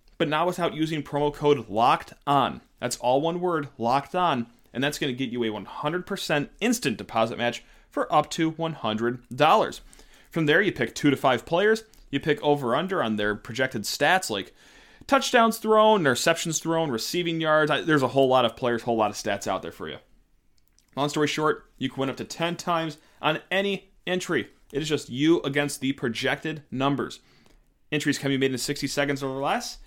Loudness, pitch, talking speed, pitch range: -25 LUFS, 145 Hz, 195 wpm, 120-165 Hz